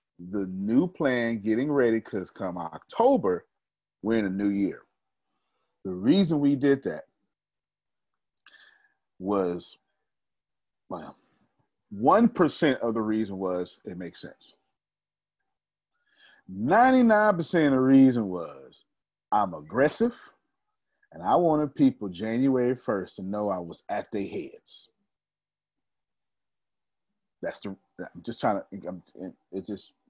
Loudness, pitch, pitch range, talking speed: -25 LUFS, 125 Hz, 100-165 Hz, 115 wpm